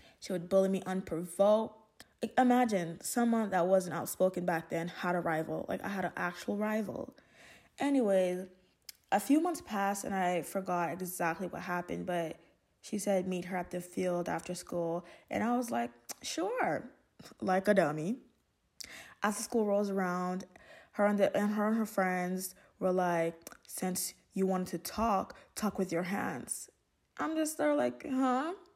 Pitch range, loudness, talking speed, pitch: 180-220 Hz, -33 LUFS, 165 wpm, 190 Hz